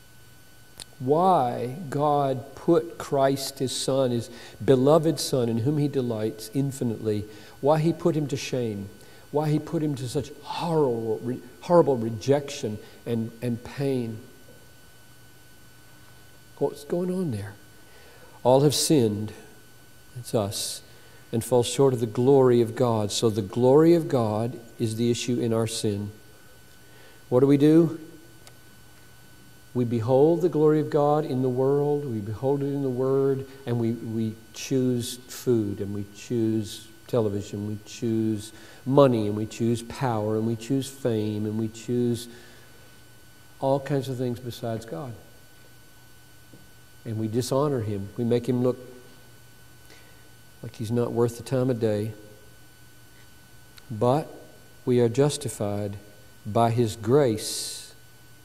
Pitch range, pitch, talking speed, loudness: 110-135 Hz, 120 Hz, 135 wpm, -25 LUFS